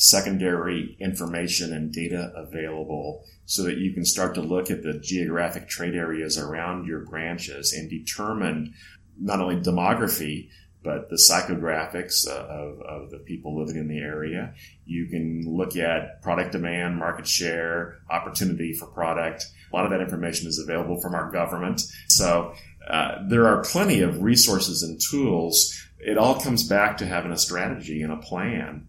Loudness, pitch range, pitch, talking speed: -24 LUFS, 80-90 Hz, 85 Hz, 160 wpm